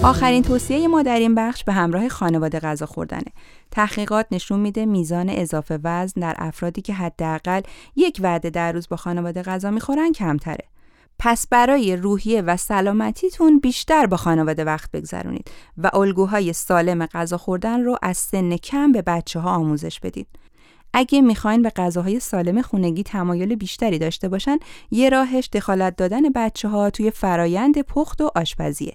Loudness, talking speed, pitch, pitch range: -20 LUFS, 155 wpm, 195 Hz, 175-235 Hz